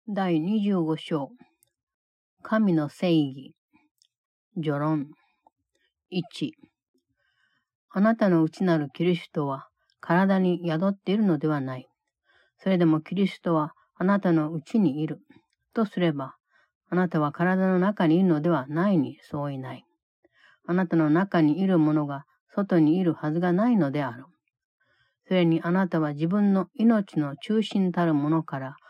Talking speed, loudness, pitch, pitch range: 250 characters per minute, -25 LUFS, 170 Hz, 155-195 Hz